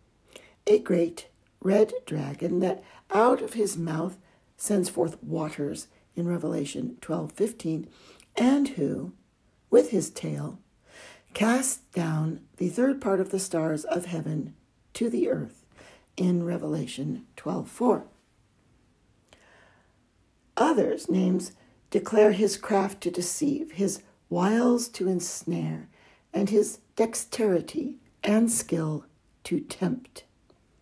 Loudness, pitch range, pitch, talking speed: -27 LUFS, 155-210 Hz, 180 Hz, 110 wpm